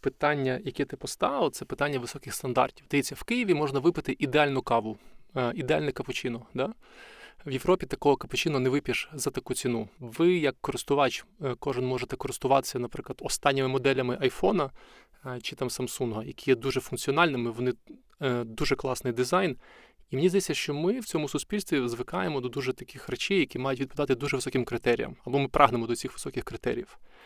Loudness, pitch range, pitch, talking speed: -29 LUFS, 125-150 Hz, 135 Hz, 165 wpm